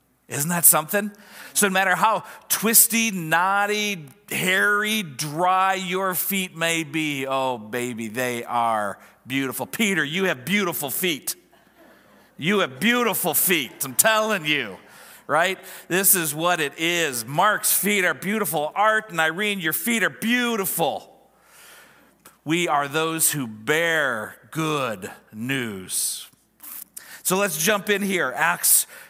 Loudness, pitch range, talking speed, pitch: -21 LUFS, 150-205 Hz, 130 wpm, 175 Hz